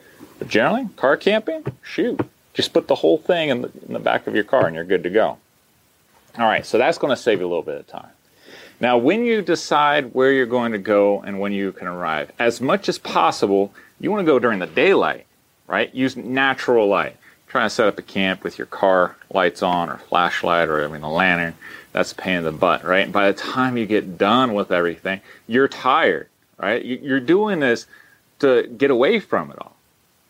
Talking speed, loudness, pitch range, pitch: 220 wpm, -19 LUFS, 95-135 Hz, 105 Hz